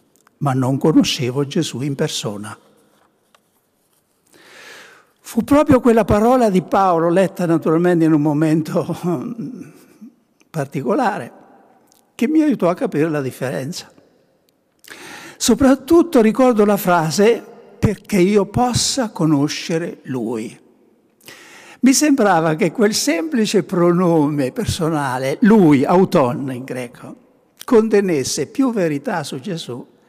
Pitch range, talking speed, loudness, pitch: 155-230 Hz, 100 wpm, -17 LUFS, 180 Hz